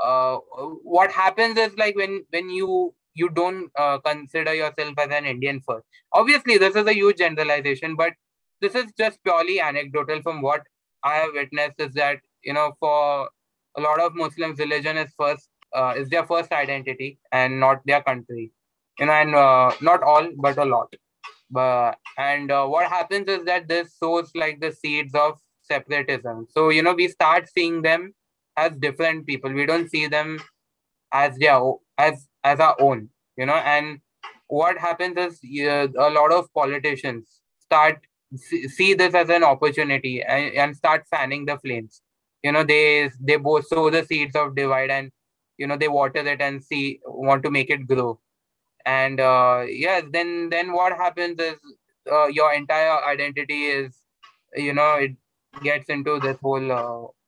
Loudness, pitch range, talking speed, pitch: -21 LUFS, 140-170 Hz, 175 wpm, 150 Hz